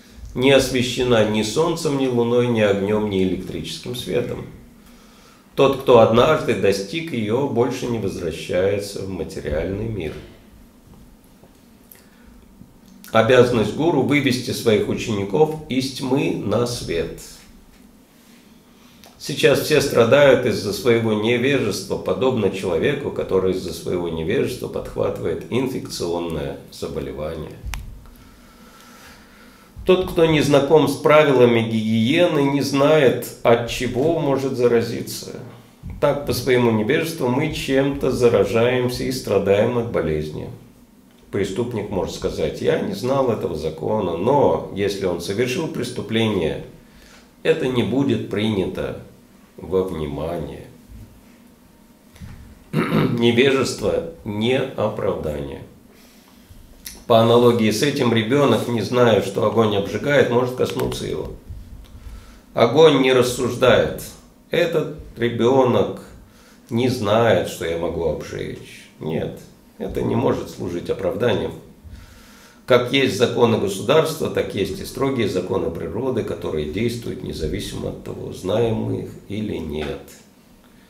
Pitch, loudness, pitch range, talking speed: 120 Hz, -20 LUFS, 105-135 Hz, 105 wpm